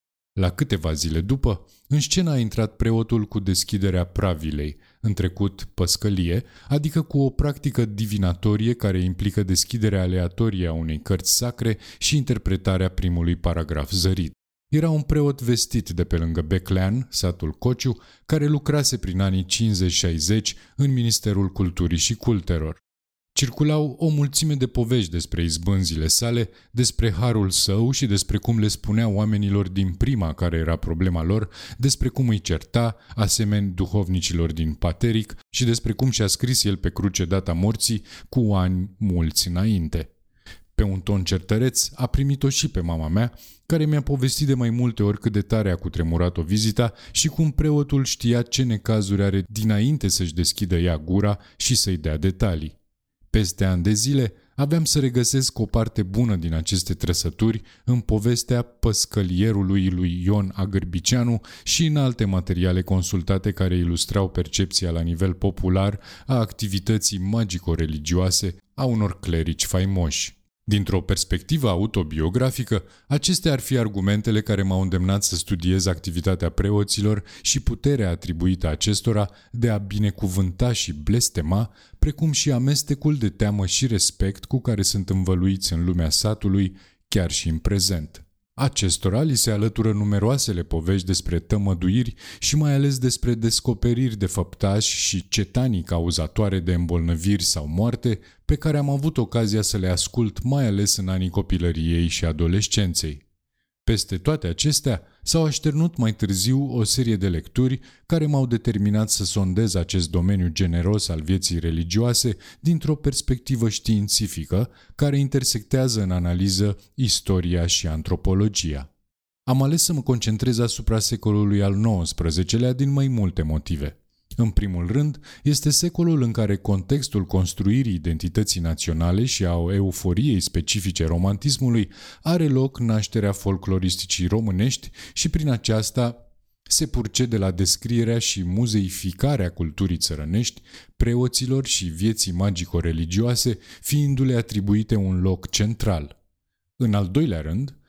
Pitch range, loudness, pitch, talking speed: 90-120 Hz, -22 LUFS, 100 Hz, 140 wpm